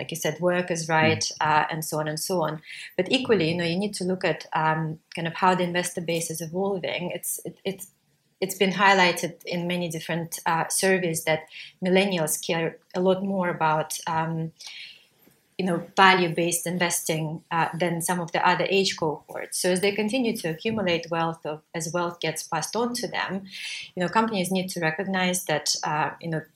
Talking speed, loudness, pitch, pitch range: 195 wpm, -25 LUFS, 175 Hz, 160-185 Hz